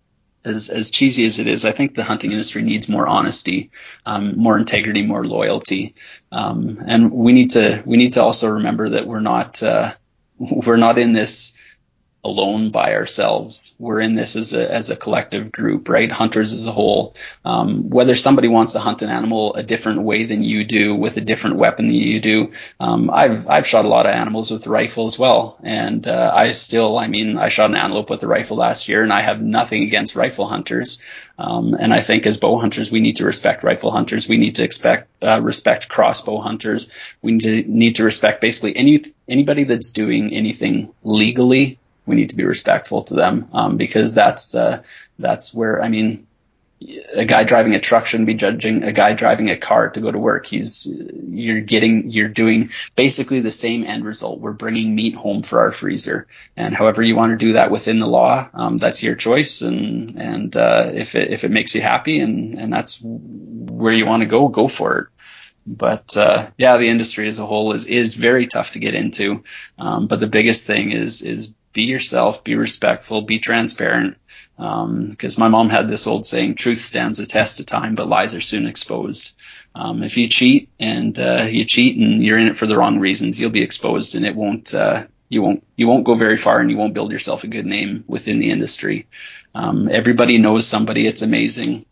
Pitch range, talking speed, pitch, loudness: 110-120 Hz, 210 wpm, 115 Hz, -15 LUFS